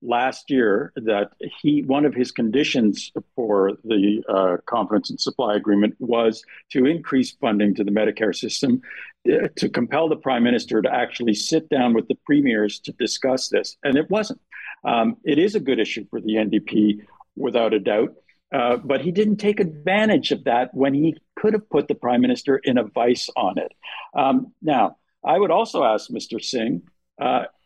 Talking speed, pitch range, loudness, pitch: 180 wpm, 110-160 Hz, -21 LUFS, 130 Hz